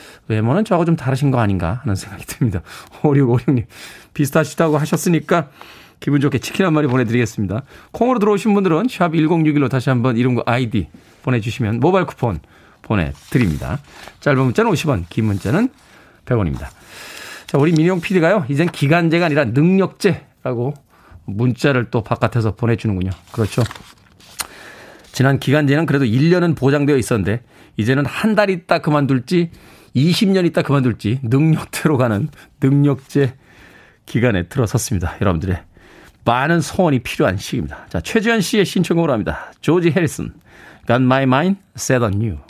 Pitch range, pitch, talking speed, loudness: 115-165 Hz, 135 Hz, 355 characters per minute, -17 LUFS